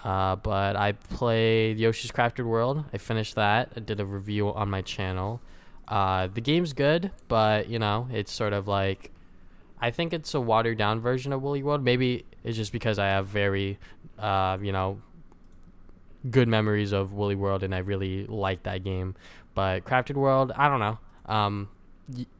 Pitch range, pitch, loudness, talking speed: 95-120 Hz, 105 Hz, -27 LUFS, 180 wpm